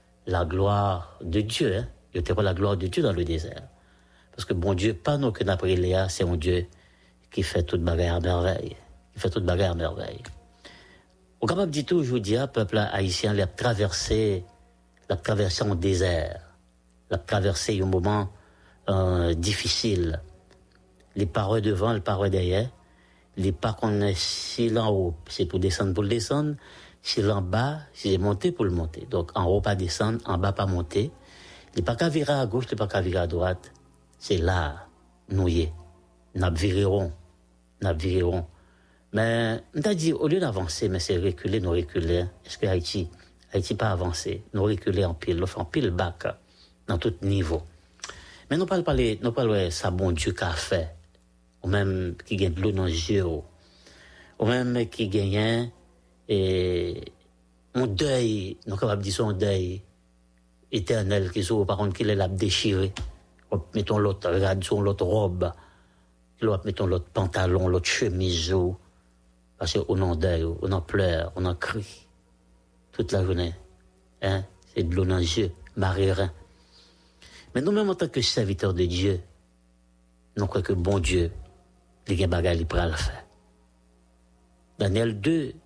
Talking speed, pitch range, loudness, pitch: 160 wpm, 85-105 Hz, -26 LUFS, 95 Hz